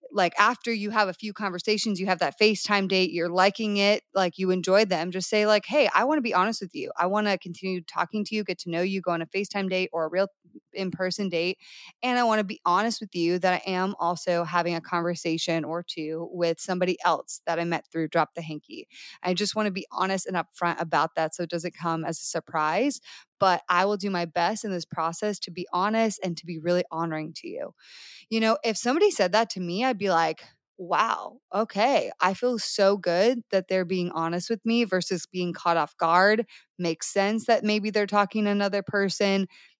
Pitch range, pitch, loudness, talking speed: 175-210 Hz, 185 Hz, -26 LUFS, 225 wpm